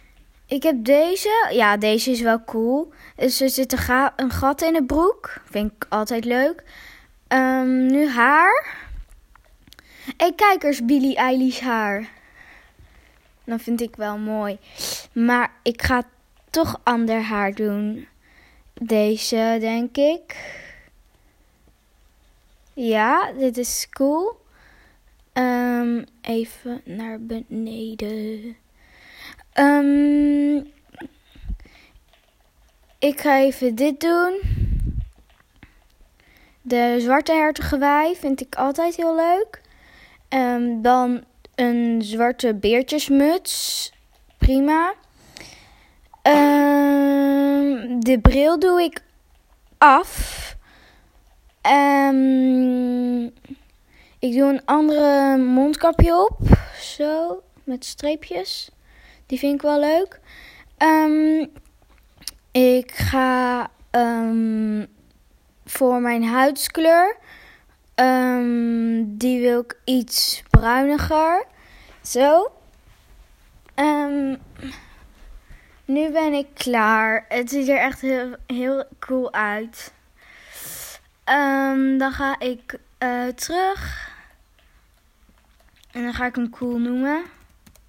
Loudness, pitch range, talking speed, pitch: -20 LUFS, 235-290 Hz, 90 wpm, 260 Hz